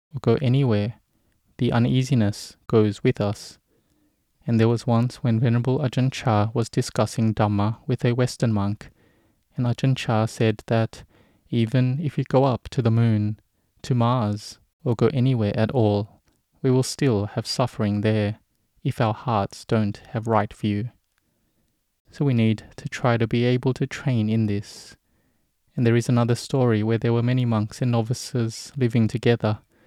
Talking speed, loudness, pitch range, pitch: 165 wpm, -23 LUFS, 110-125 Hz, 115 Hz